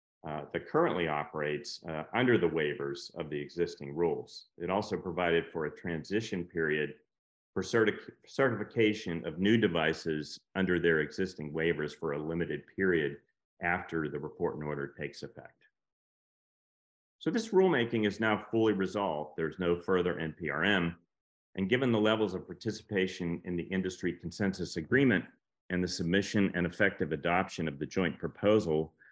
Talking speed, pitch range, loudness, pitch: 150 wpm, 80-100 Hz, -32 LUFS, 85 Hz